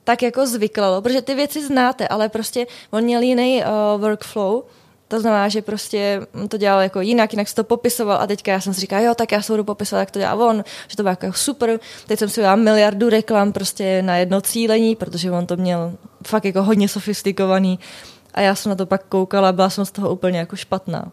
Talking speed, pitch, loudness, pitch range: 225 wpm, 210 Hz, -19 LUFS, 195-225 Hz